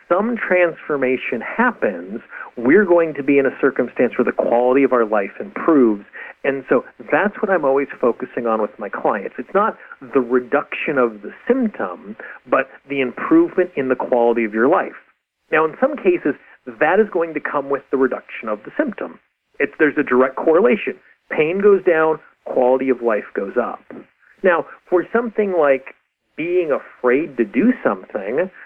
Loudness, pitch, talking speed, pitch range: -18 LUFS, 145 Hz, 170 wpm, 130-190 Hz